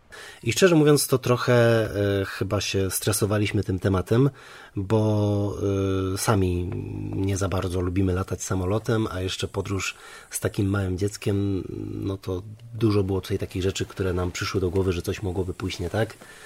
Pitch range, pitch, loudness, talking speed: 95-110 Hz, 100 Hz, -25 LUFS, 165 wpm